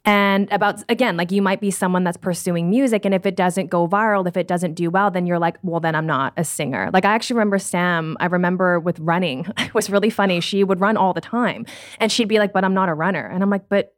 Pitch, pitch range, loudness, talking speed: 190 Hz, 175-205 Hz, -19 LUFS, 270 wpm